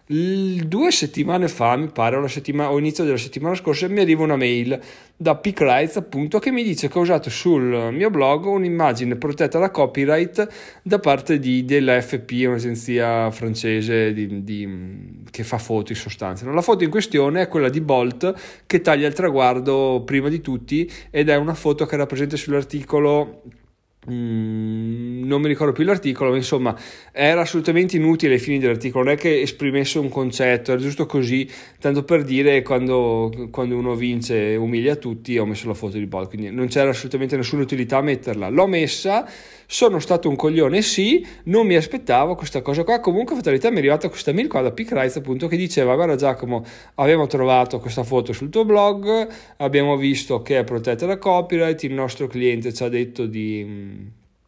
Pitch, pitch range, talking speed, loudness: 140 Hz, 120-160 Hz, 180 wpm, -20 LUFS